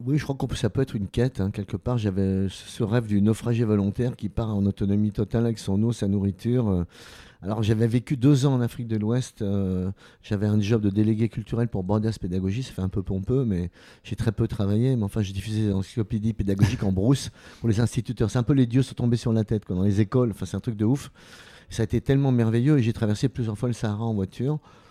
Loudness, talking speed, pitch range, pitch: -25 LUFS, 250 wpm, 100-120 Hz, 110 Hz